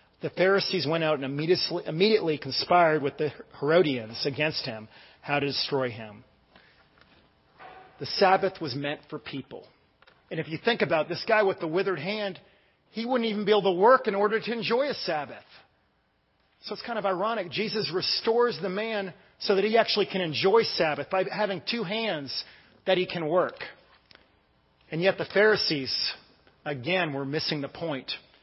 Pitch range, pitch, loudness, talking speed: 150-210 Hz, 185 Hz, -26 LUFS, 170 wpm